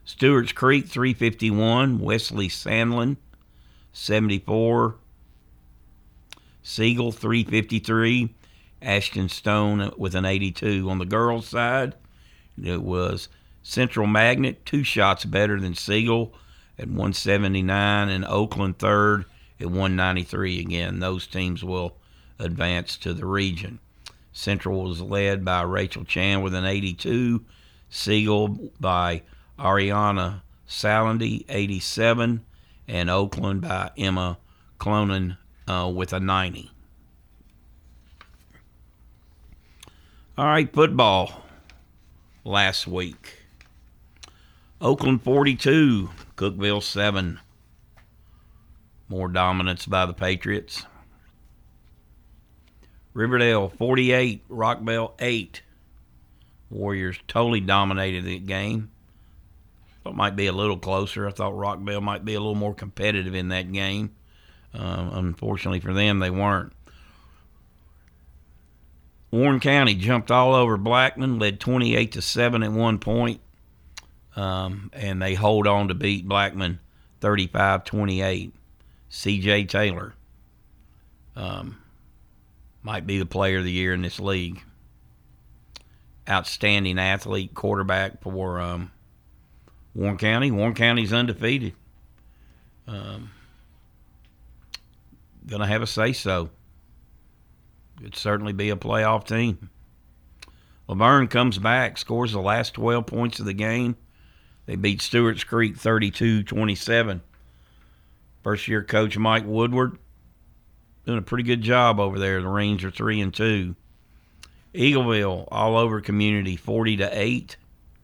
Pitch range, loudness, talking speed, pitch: 85-110 Hz, -23 LUFS, 110 wpm, 95 Hz